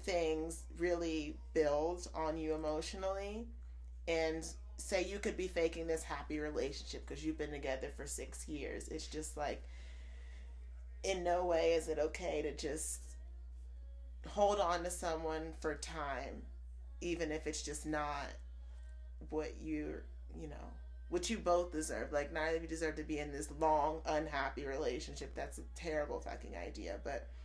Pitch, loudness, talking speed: 150 Hz, -40 LUFS, 155 wpm